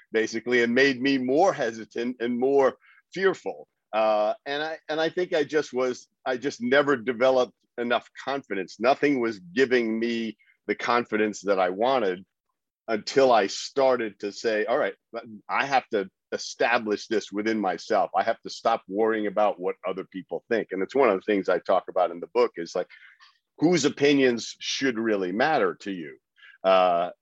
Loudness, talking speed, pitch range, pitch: -25 LUFS, 175 wpm, 110-140 Hz, 120 Hz